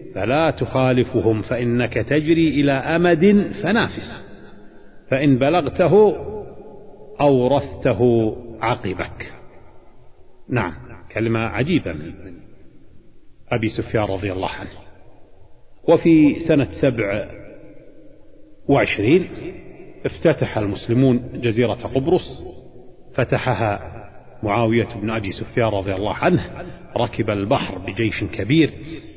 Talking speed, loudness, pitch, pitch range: 80 wpm, -19 LUFS, 120 Hz, 110-140 Hz